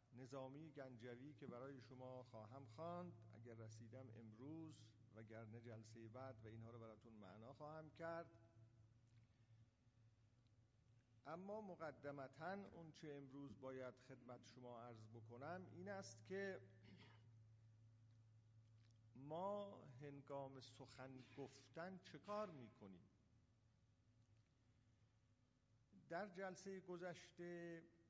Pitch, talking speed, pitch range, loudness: 120 Hz, 90 wpm, 115-150 Hz, -57 LUFS